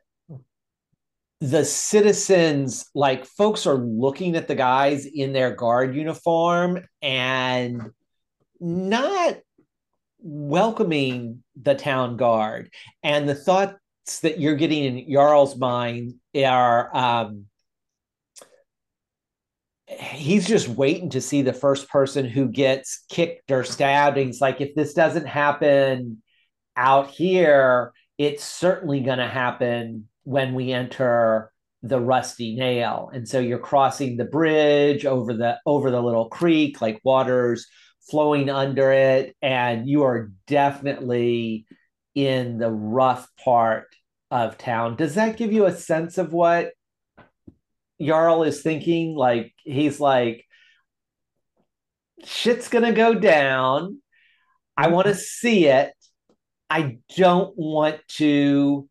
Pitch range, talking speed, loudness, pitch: 125-160 Hz, 120 wpm, -21 LUFS, 140 Hz